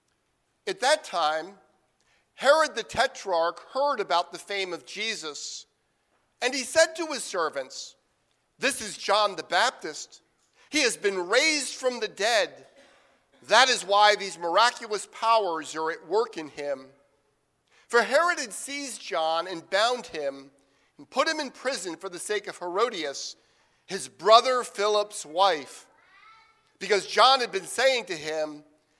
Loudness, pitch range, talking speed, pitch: -25 LUFS, 170-265 Hz, 145 wpm, 210 Hz